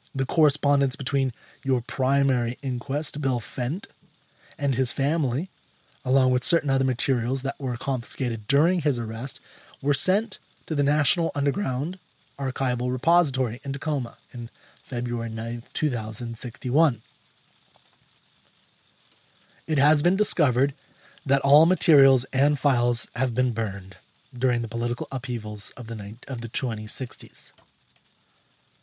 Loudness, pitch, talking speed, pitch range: -25 LUFS, 135 Hz, 125 wpm, 120-145 Hz